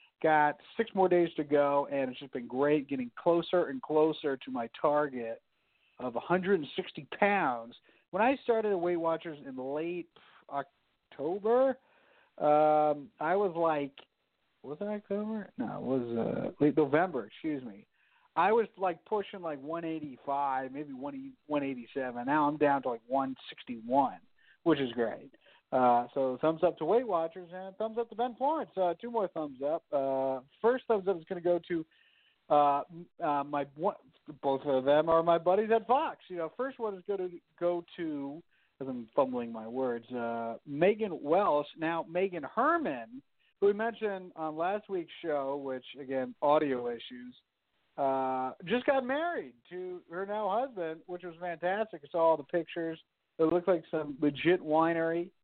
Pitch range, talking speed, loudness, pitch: 140-195 Hz, 165 wpm, -32 LUFS, 165 Hz